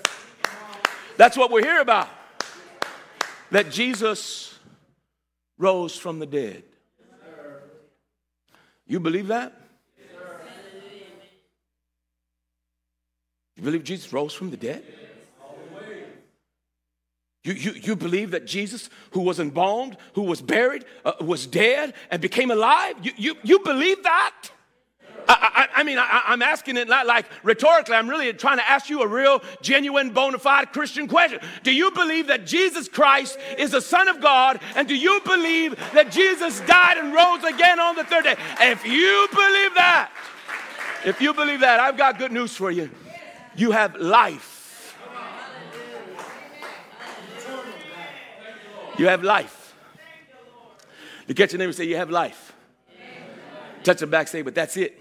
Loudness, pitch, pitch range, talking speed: -20 LUFS, 235 Hz, 180-300 Hz, 140 wpm